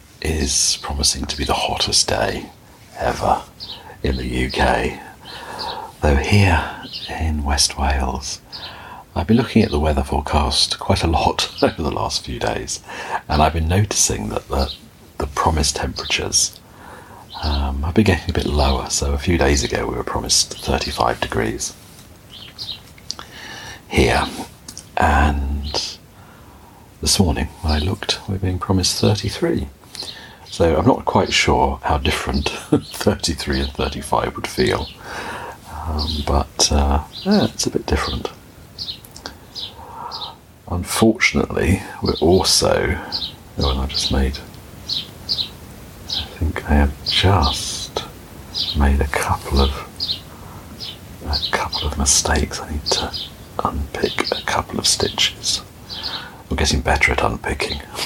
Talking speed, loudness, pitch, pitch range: 125 wpm, -19 LUFS, 80 Hz, 70-95 Hz